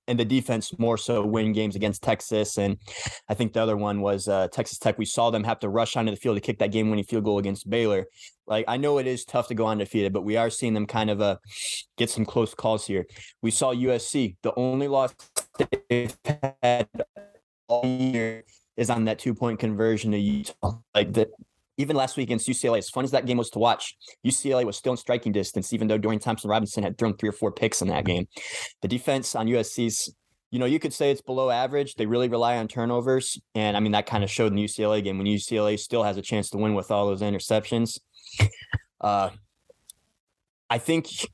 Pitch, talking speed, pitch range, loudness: 110 Hz, 220 wpm, 105-120 Hz, -26 LUFS